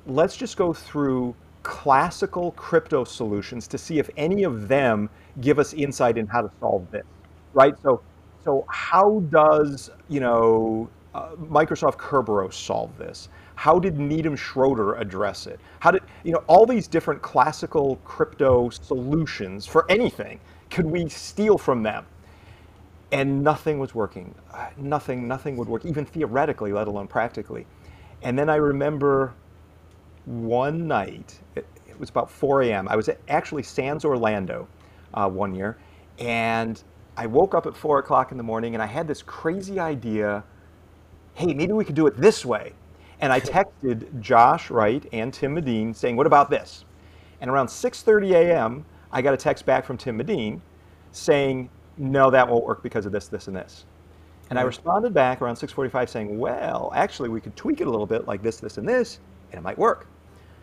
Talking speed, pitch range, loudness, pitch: 170 wpm, 100-150 Hz, -23 LUFS, 125 Hz